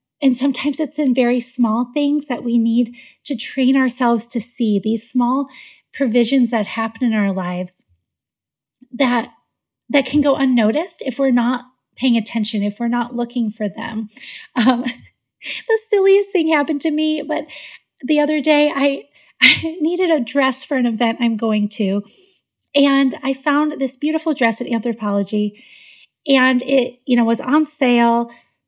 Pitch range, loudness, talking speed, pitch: 230-285 Hz, -18 LUFS, 160 wpm, 255 Hz